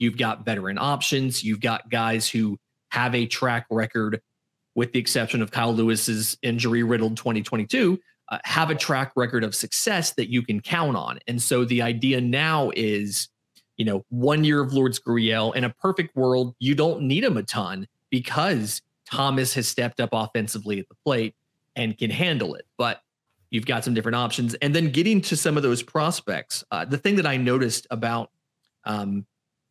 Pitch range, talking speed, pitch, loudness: 115-140 Hz, 185 wpm, 120 Hz, -24 LUFS